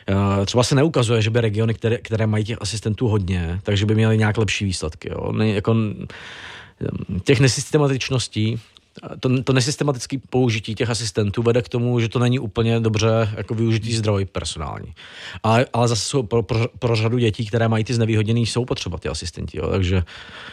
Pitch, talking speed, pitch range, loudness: 115 Hz, 170 wpm, 105-120 Hz, -21 LUFS